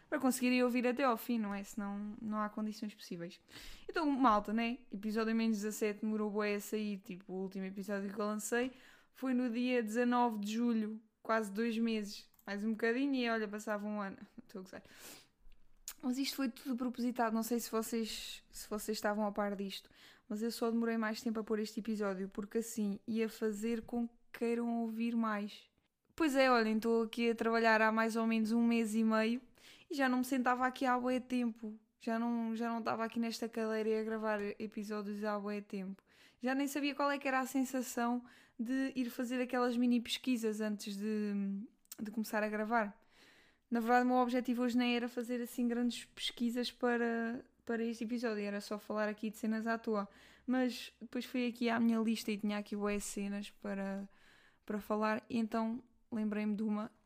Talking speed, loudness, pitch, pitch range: 200 wpm, -37 LUFS, 225 Hz, 215-245 Hz